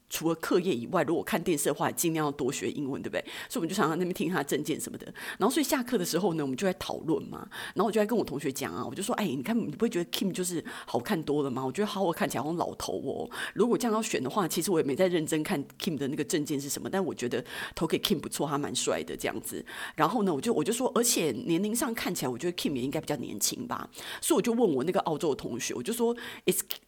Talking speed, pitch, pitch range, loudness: 445 characters per minute, 185 Hz, 160-230 Hz, -30 LUFS